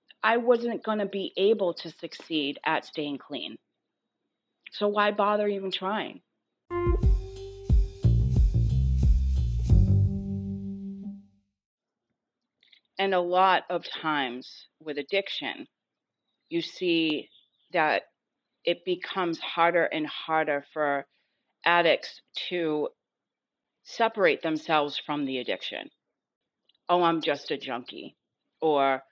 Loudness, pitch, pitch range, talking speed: -27 LUFS, 160 Hz, 115-190 Hz, 95 wpm